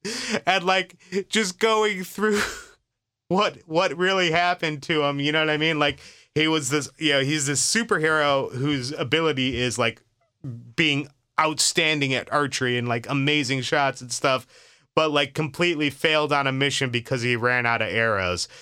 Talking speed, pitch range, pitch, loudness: 170 wpm, 135-170 Hz, 150 Hz, -22 LUFS